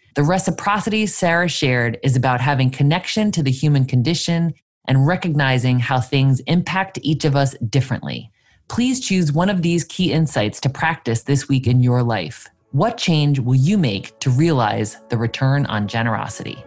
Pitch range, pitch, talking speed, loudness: 125-170 Hz, 140 Hz, 165 wpm, -18 LUFS